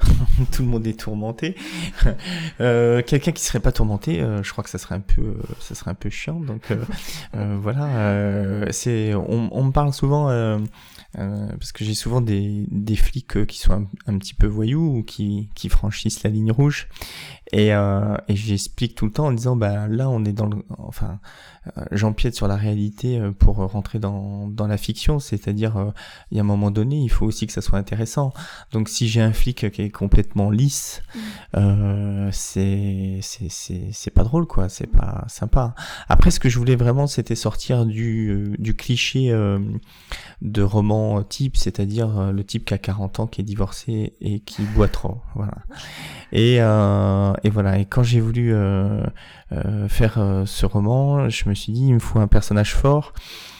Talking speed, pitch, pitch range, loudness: 200 wpm, 105 Hz, 100-120 Hz, -22 LUFS